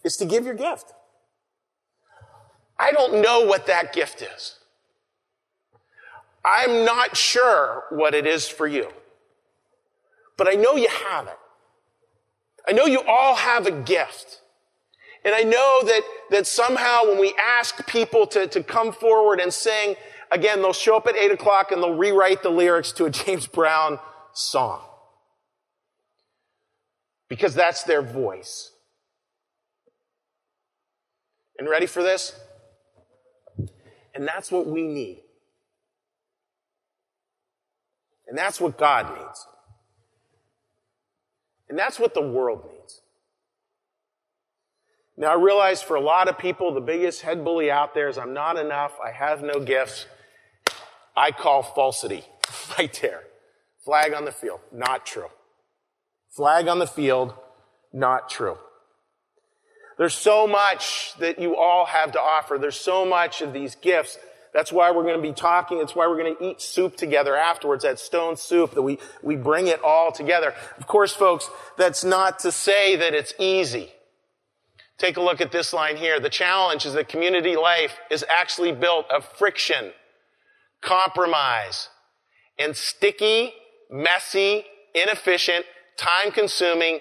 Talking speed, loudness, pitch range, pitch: 140 wpm, -21 LUFS, 155-230 Hz, 180 Hz